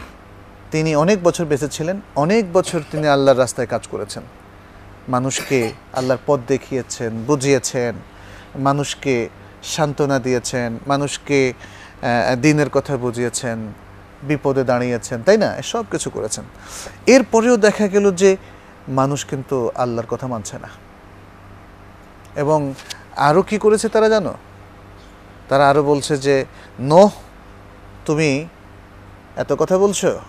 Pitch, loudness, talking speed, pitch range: 130 Hz, -18 LUFS, 110 wpm, 100-150 Hz